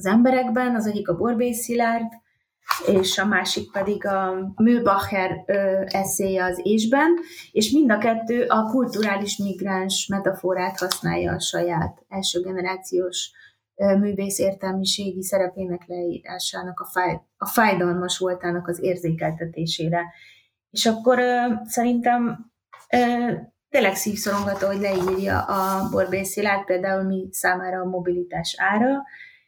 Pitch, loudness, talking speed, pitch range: 195 Hz, -22 LUFS, 115 wpm, 185-225 Hz